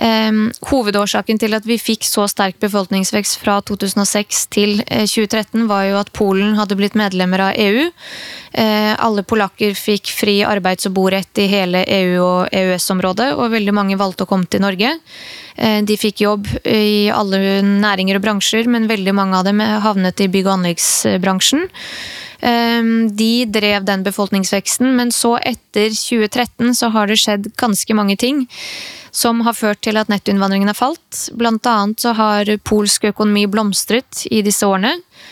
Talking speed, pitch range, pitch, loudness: 160 wpm, 200-225 Hz, 210 Hz, -15 LUFS